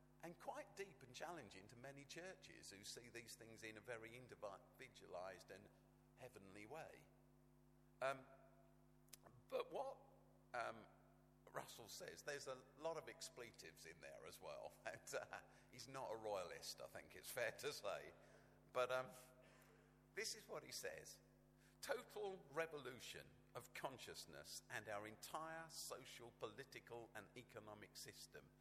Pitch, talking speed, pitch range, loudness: 130 Hz, 135 wpm, 115-160 Hz, -54 LUFS